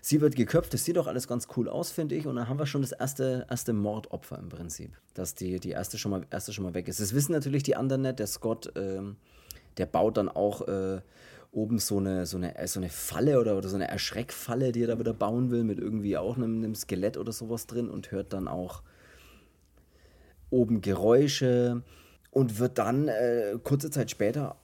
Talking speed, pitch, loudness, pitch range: 215 wpm, 110 Hz, -30 LUFS, 95-125 Hz